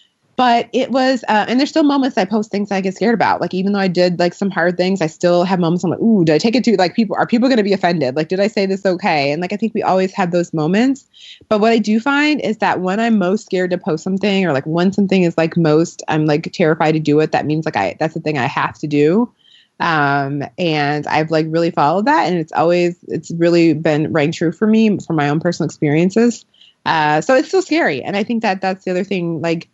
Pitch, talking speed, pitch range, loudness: 180 Hz, 270 wpm, 160-215 Hz, -16 LUFS